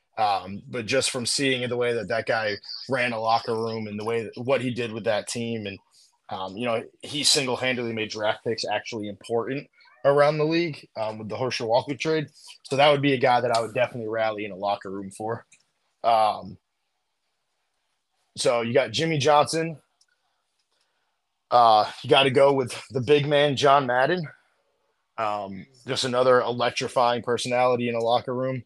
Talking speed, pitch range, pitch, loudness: 180 wpm, 115-140 Hz, 125 Hz, -24 LUFS